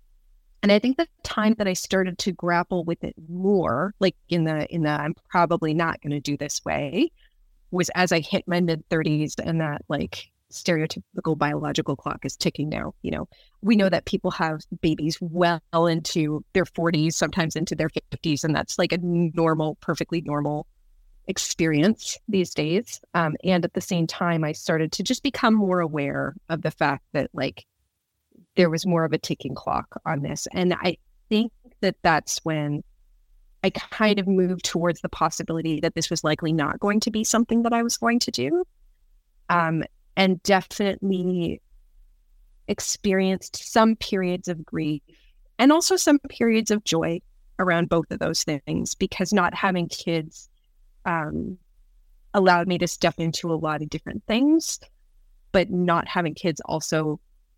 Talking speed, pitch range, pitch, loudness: 170 wpm, 160-195 Hz, 175 Hz, -24 LUFS